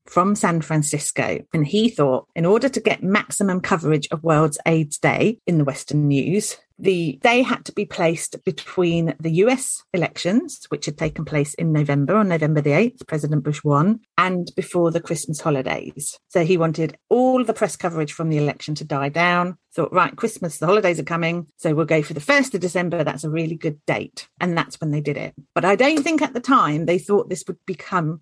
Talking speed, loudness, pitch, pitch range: 210 wpm, -20 LUFS, 165 Hz, 150-190 Hz